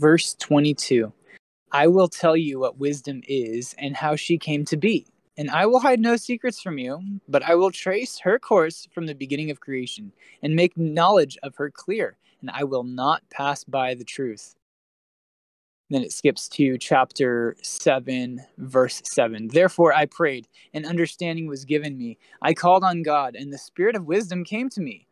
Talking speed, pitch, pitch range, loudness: 180 wpm, 150 Hz, 135-180 Hz, -23 LUFS